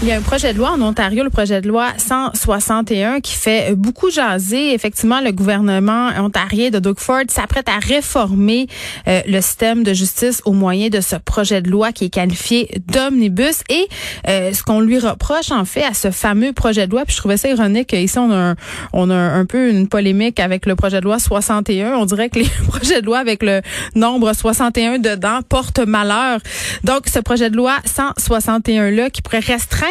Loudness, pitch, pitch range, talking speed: -15 LUFS, 225 Hz, 200-245 Hz, 205 wpm